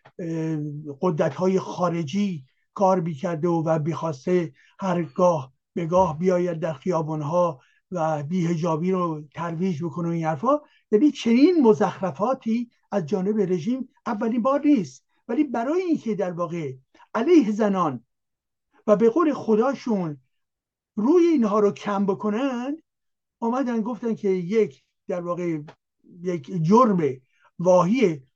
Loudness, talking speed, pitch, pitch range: -23 LUFS, 125 wpm, 185 Hz, 165-225 Hz